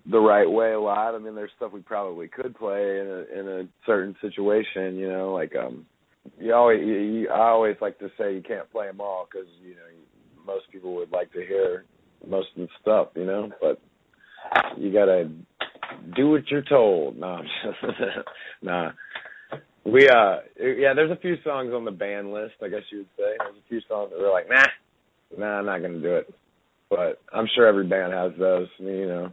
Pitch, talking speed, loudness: 110 Hz, 210 wpm, -24 LUFS